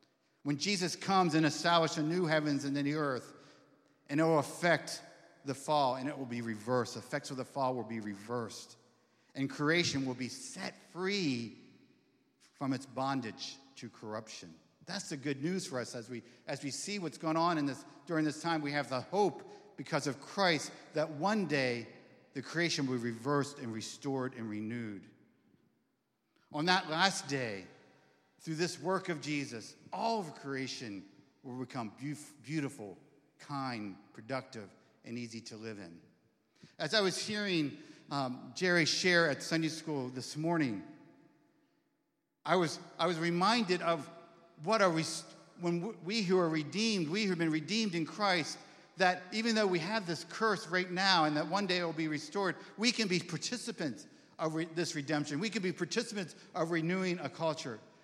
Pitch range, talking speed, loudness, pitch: 130-180 Hz, 175 wpm, -34 LUFS, 155 Hz